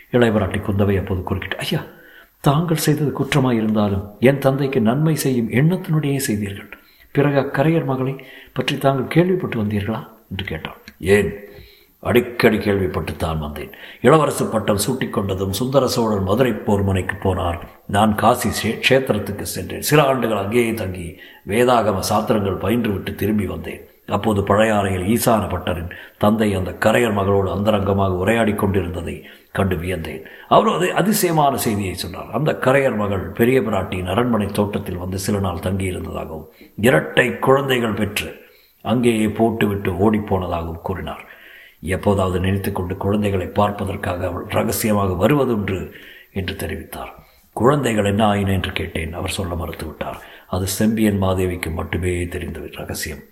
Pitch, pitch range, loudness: 100 Hz, 95-115 Hz, -19 LUFS